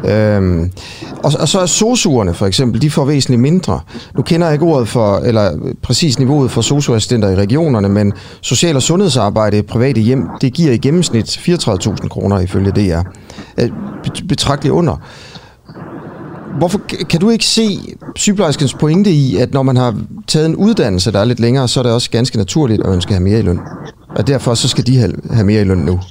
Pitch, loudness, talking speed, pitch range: 125 Hz, -13 LUFS, 190 wpm, 105-155 Hz